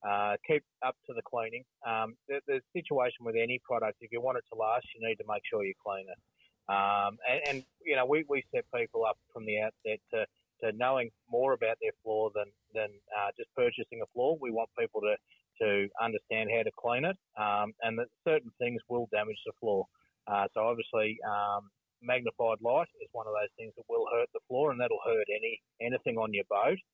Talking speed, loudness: 215 wpm, -33 LUFS